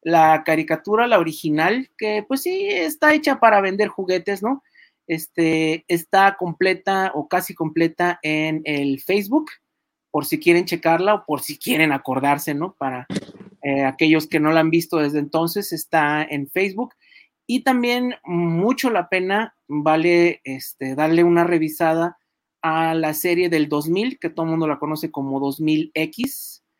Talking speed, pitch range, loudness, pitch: 150 wpm, 155-210 Hz, -20 LUFS, 170 Hz